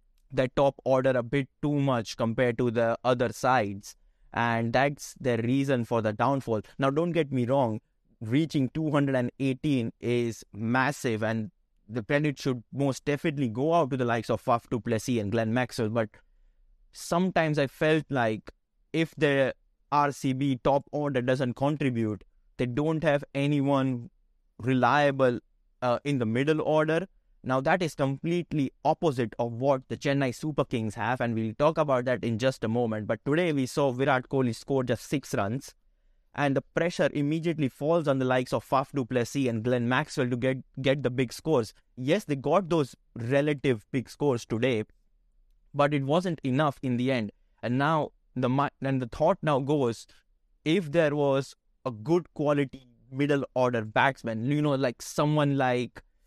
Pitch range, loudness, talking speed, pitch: 120-145 Hz, -28 LUFS, 165 wpm, 130 Hz